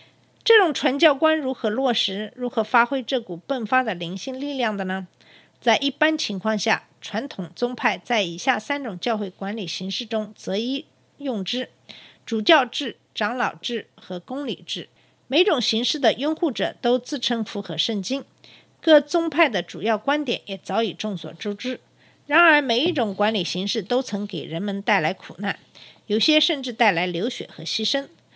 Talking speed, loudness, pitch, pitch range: 250 characters per minute, -23 LUFS, 230 Hz, 200-270 Hz